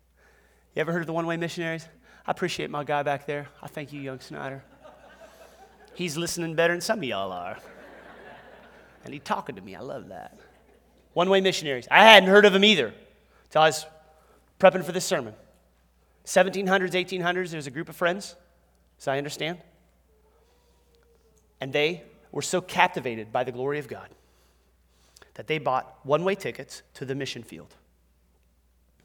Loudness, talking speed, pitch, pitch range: -24 LUFS, 170 wpm, 155 Hz, 125-175 Hz